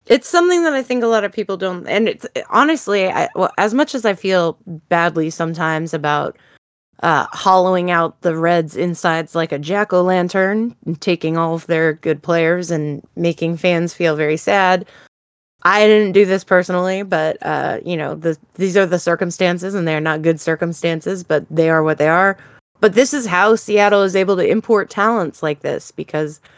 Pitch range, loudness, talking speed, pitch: 165-200 Hz, -16 LUFS, 190 wpm, 180 Hz